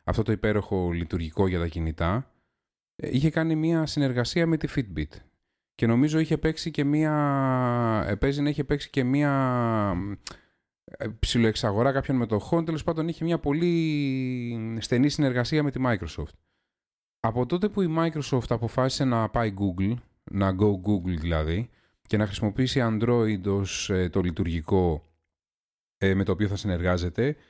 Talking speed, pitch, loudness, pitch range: 135 wpm, 115 Hz, -26 LUFS, 100-145 Hz